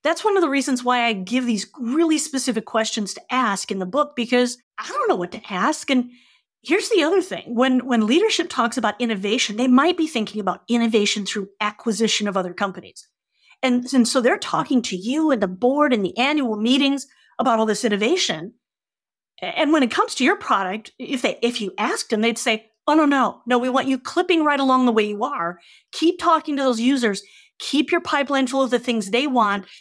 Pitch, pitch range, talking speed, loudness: 250 Hz, 220-280 Hz, 215 wpm, -20 LUFS